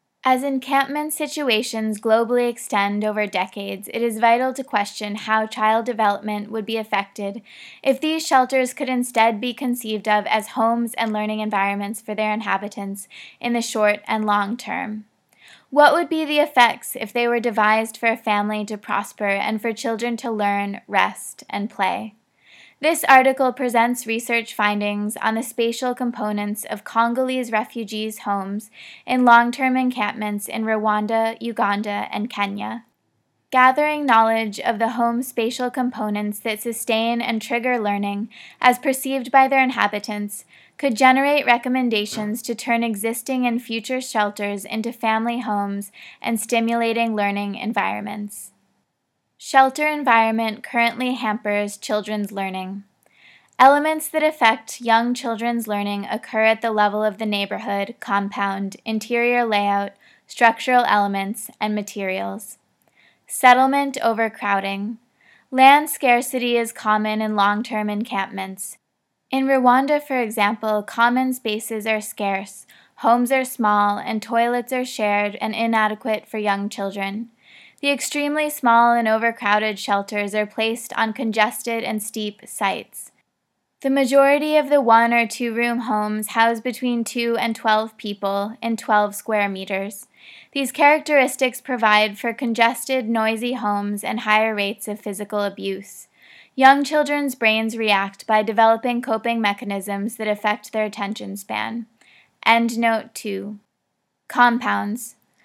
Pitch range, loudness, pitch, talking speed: 210-245 Hz, -20 LUFS, 225 Hz, 135 wpm